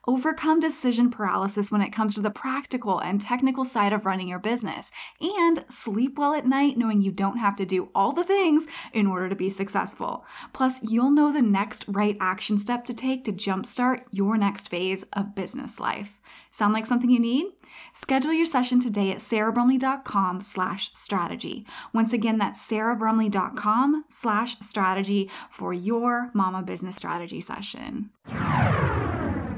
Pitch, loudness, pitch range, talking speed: 220 Hz, -25 LUFS, 195-255 Hz, 160 wpm